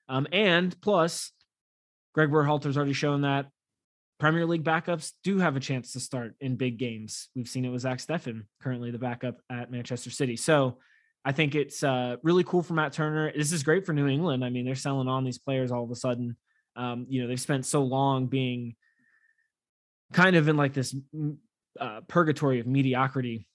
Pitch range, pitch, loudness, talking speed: 125-155 Hz, 135 Hz, -28 LUFS, 195 wpm